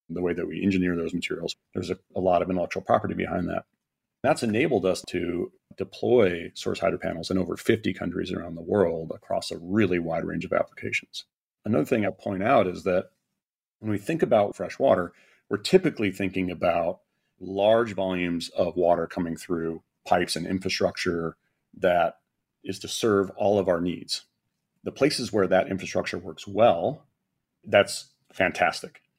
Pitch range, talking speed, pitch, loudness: 85-95 Hz, 165 wpm, 90 Hz, -26 LUFS